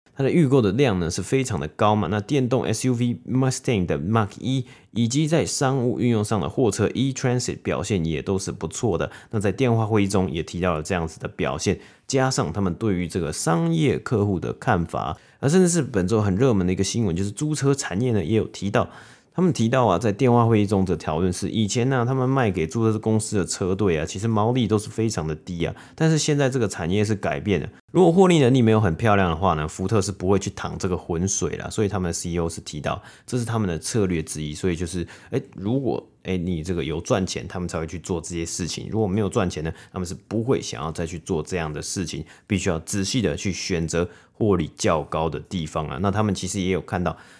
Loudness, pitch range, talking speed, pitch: -23 LUFS, 90-120 Hz, 365 characters per minute, 100 Hz